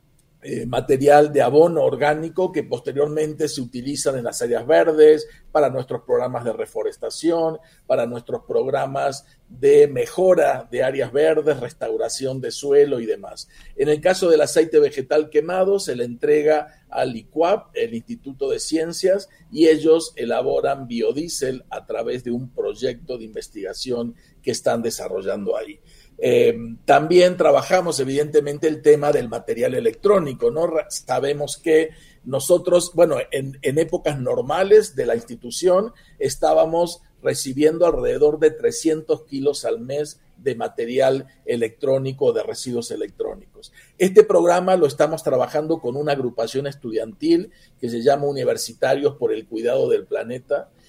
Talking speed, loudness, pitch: 135 wpm, -20 LUFS, 165 Hz